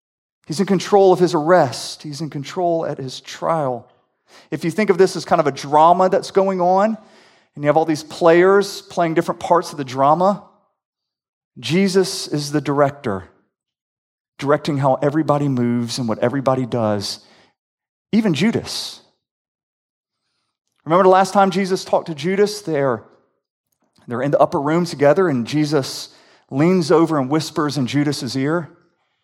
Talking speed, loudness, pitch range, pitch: 150 wpm, -18 LUFS, 140-185 Hz, 160 Hz